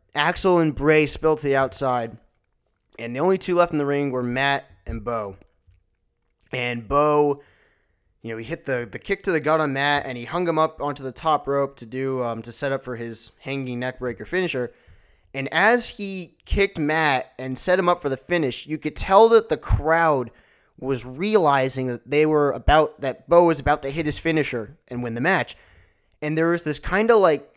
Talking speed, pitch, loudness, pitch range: 210 wpm, 140 Hz, -22 LUFS, 120-160 Hz